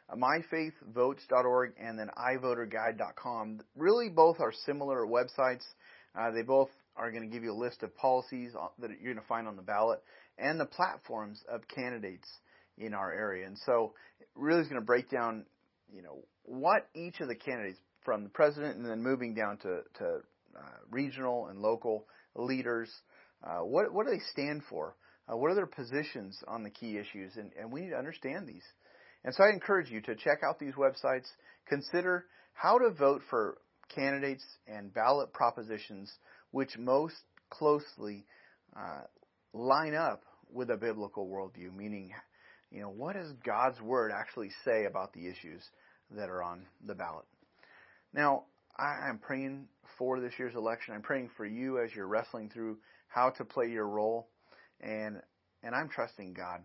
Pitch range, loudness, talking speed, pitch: 110-140 Hz, -34 LUFS, 170 wpm, 120 Hz